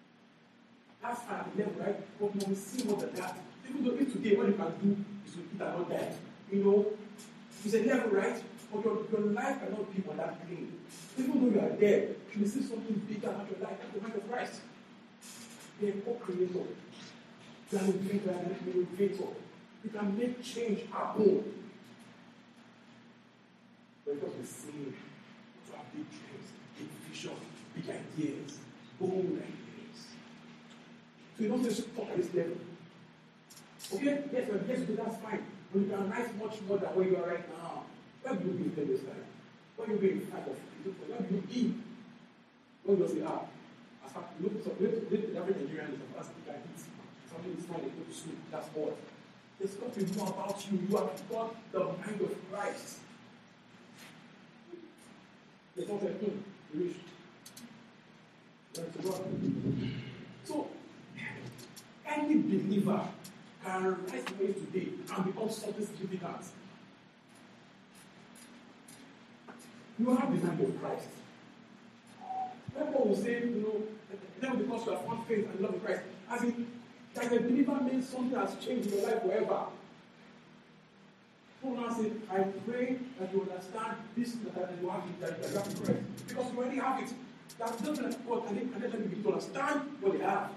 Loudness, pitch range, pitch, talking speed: -35 LUFS, 195-235 Hz, 215 Hz, 165 wpm